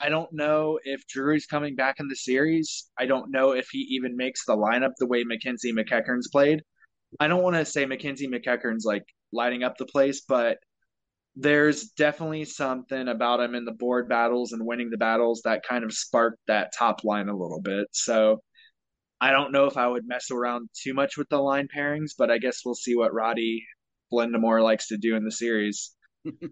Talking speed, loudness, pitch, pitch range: 205 wpm, -26 LUFS, 125 Hz, 115-140 Hz